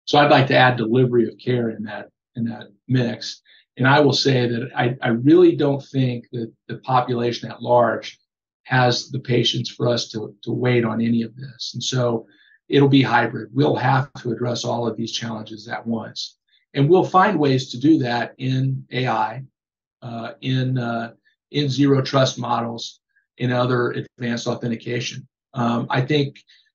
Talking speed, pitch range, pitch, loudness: 175 wpm, 115-135 Hz, 120 Hz, -20 LUFS